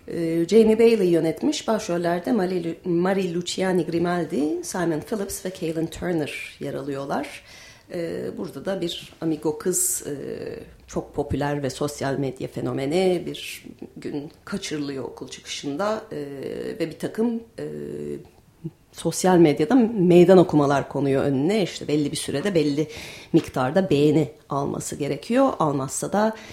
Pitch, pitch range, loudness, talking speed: 165 Hz, 145-190 Hz, -23 LUFS, 125 wpm